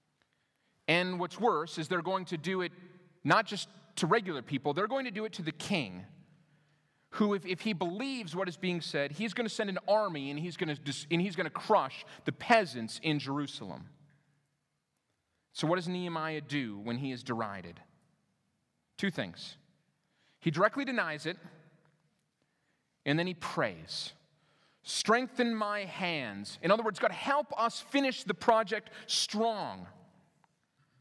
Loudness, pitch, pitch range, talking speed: -33 LUFS, 175 Hz, 150-210 Hz, 160 wpm